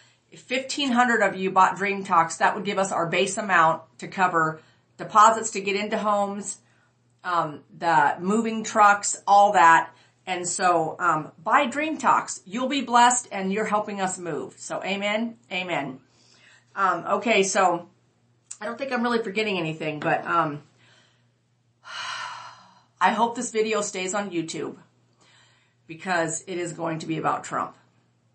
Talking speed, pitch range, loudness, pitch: 150 wpm, 160-215 Hz, -23 LUFS, 185 Hz